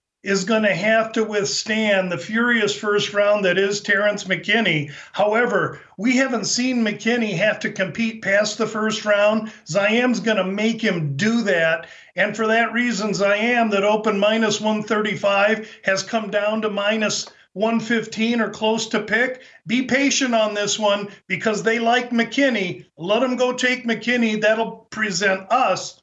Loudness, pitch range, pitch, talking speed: -20 LUFS, 200-225 Hz, 215 Hz, 165 wpm